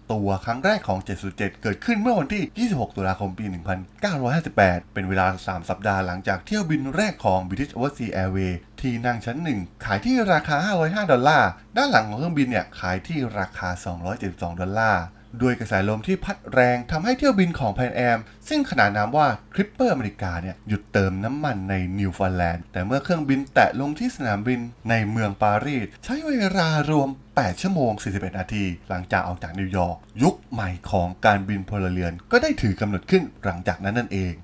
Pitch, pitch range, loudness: 105 Hz, 95-145 Hz, -23 LUFS